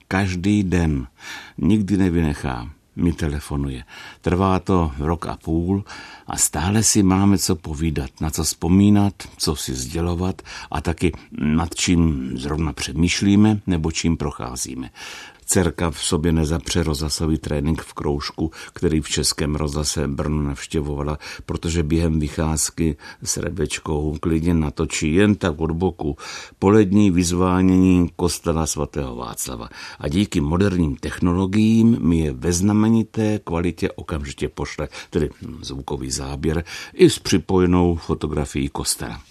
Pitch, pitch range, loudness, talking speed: 85 Hz, 75-95 Hz, -21 LUFS, 120 wpm